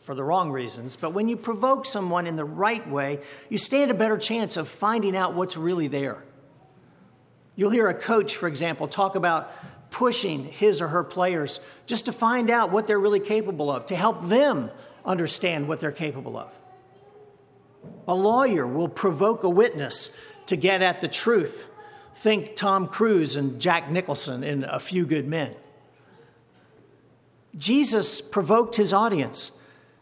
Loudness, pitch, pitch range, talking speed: -24 LUFS, 195 Hz, 160-225 Hz, 160 wpm